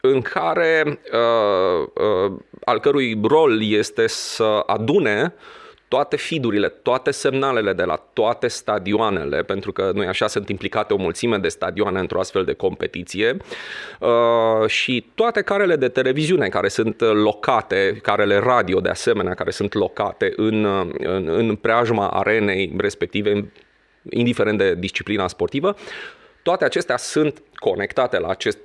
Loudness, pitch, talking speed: -20 LUFS, 150 Hz, 135 wpm